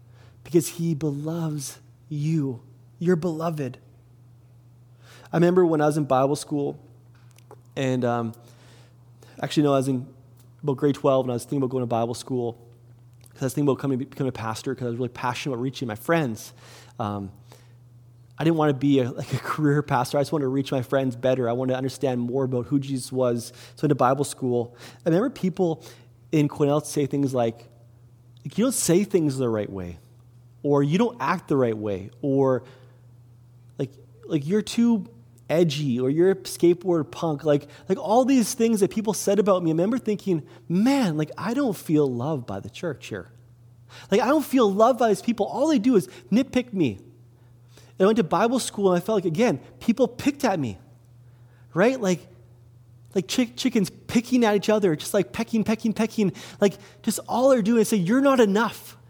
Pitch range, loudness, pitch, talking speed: 120-180 Hz, -24 LUFS, 135 Hz, 195 wpm